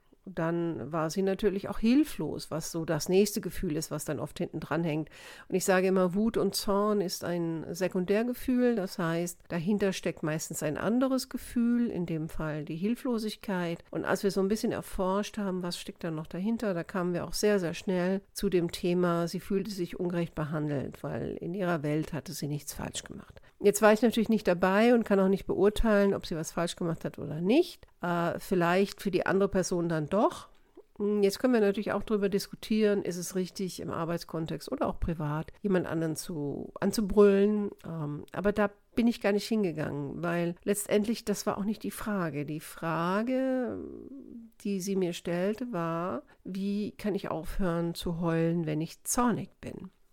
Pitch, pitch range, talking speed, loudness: 190 Hz, 170-205 Hz, 190 wpm, -30 LUFS